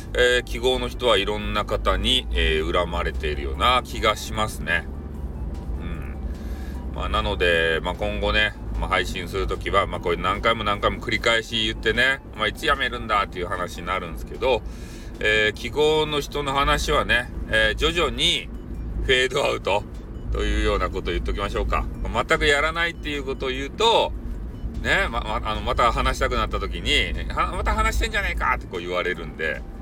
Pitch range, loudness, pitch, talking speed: 80-120 Hz, -23 LUFS, 105 Hz, 370 characters per minute